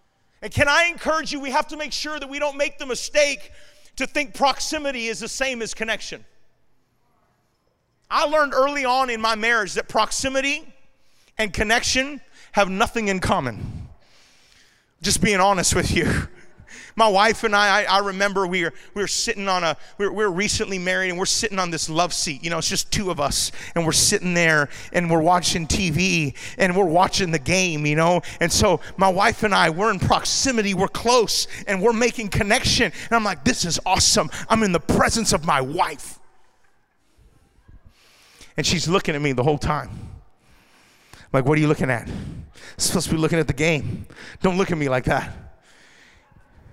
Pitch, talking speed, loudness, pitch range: 200 Hz, 195 wpm, -20 LUFS, 175-240 Hz